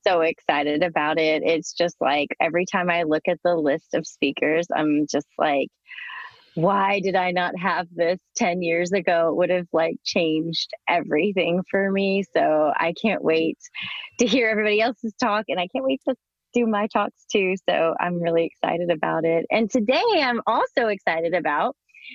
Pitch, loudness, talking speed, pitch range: 180 Hz, -22 LUFS, 180 wpm, 165-210 Hz